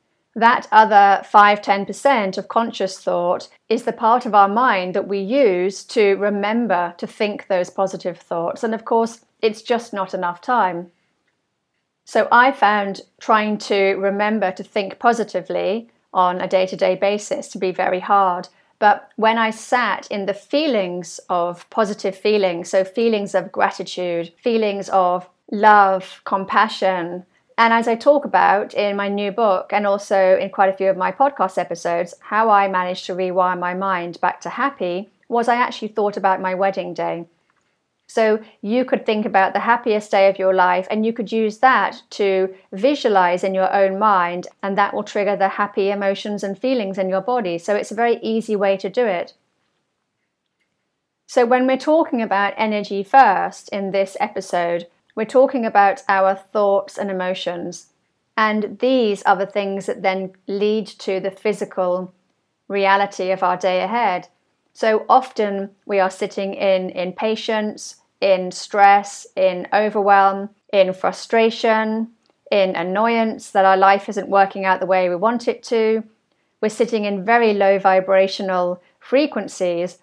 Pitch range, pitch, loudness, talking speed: 190-220 Hz, 200 Hz, -18 LUFS, 160 wpm